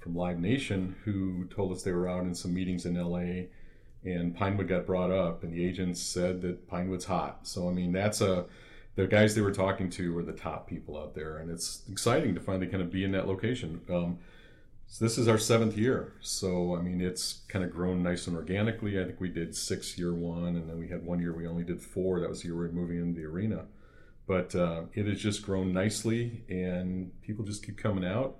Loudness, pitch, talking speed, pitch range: -32 LUFS, 90 Hz, 235 wpm, 85-100 Hz